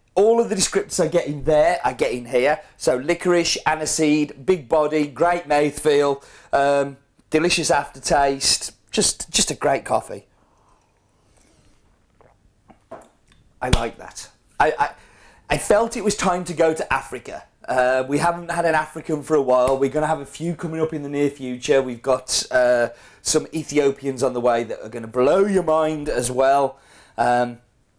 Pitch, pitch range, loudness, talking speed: 150 Hz, 135-165 Hz, -20 LUFS, 175 wpm